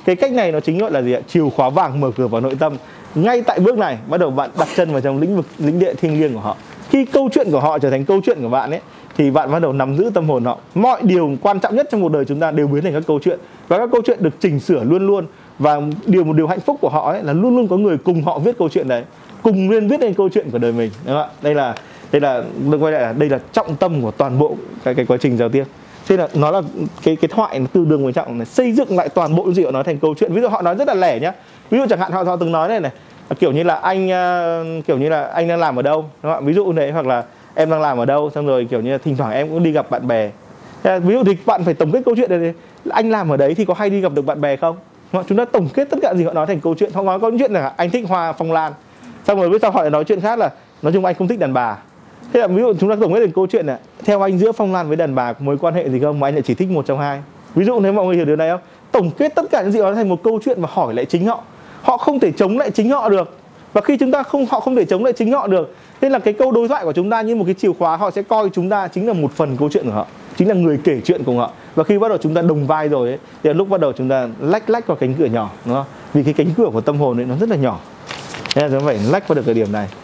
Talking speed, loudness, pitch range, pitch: 330 wpm, -17 LUFS, 145-200 Hz, 170 Hz